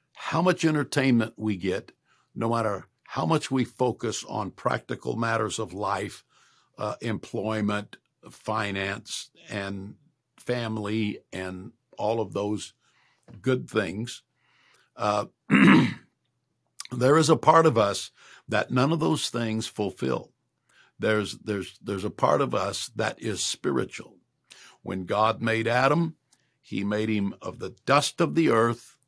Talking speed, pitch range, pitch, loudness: 130 wpm, 105-130 Hz, 115 Hz, -26 LUFS